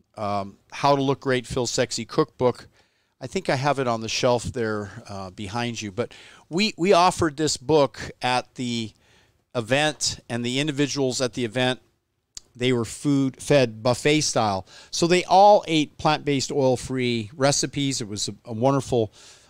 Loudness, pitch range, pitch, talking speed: -23 LUFS, 115-140 Hz, 125 Hz, 165 wpm